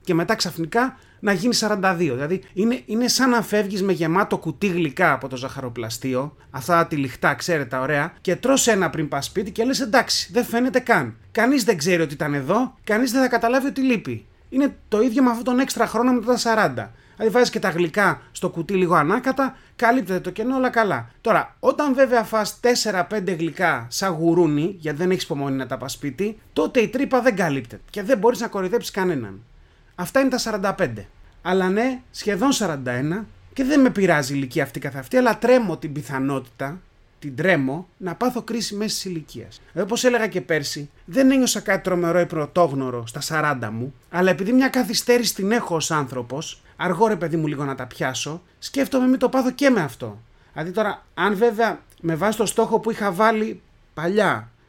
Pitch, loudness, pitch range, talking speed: 190 Hz, -21 LUFS, 150-235 Hz, 190 wpm